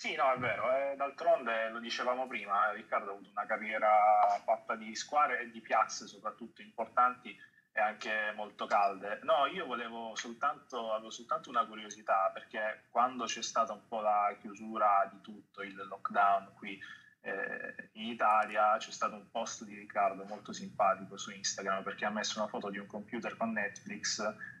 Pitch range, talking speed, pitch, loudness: 105-140 Hz, 170 wpm, 115 Hz, -34 LUFS